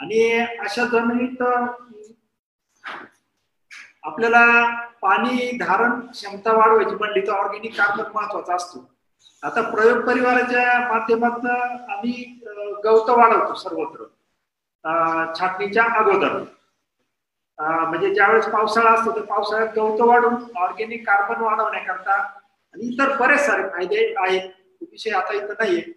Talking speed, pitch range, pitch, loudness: 105 wpm, 205-240 Hz, 225 Hz, -19 LUFS